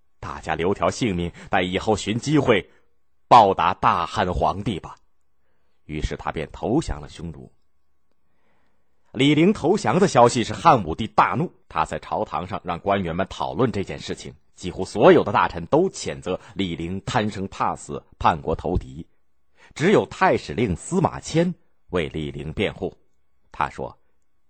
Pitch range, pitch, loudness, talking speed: 75-110 Hz, 85 Hz, -22 LUFS, 225 characters per minute